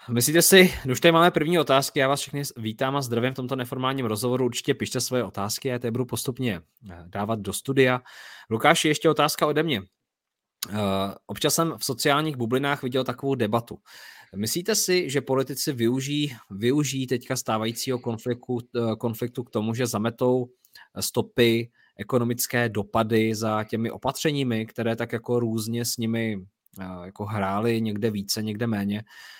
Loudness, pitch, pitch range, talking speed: -24 LUFS, 120 Hz, 110-135 Hz, 155 wpm